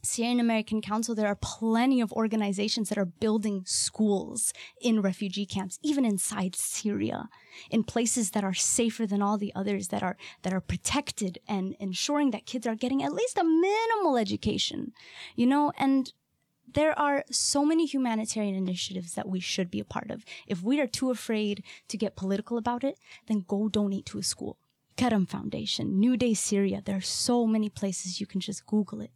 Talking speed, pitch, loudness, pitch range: 185 wpm, 215 Hz, -28 LUFS, 195-245 Hz